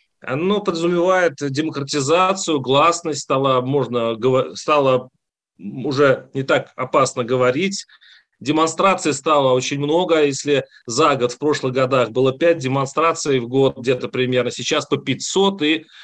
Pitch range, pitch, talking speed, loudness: 130-160 Hz, 145 Hz, 125 wpm, -18 LUFS